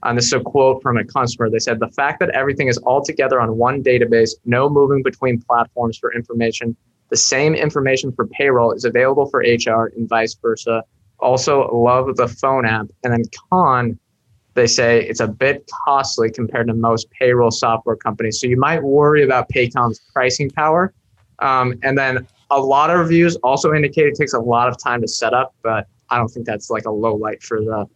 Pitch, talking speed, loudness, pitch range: 120 Hz, 205 wpm, -17 LUFS, 115-135 Hz